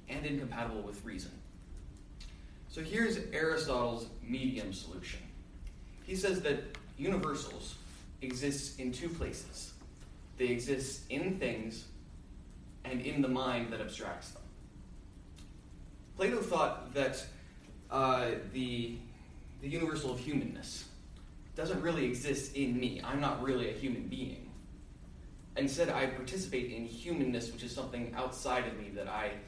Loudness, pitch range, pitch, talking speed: -37 LUFS, 95-135 Hz, 120 Hz, 125 wpm